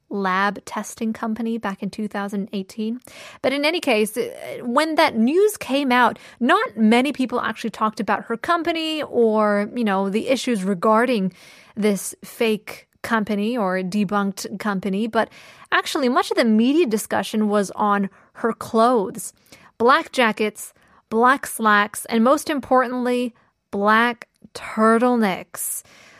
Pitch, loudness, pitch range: 225 Hz, -21 LUFS, 210-250 Hz